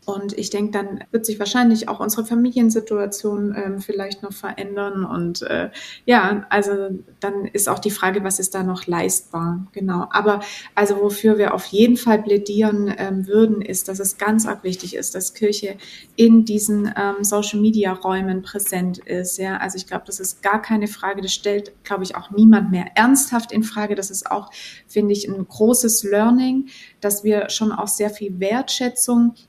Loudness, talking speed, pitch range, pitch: -19 LUFS, 180 wpm, 195-215 Hz, 205 Hz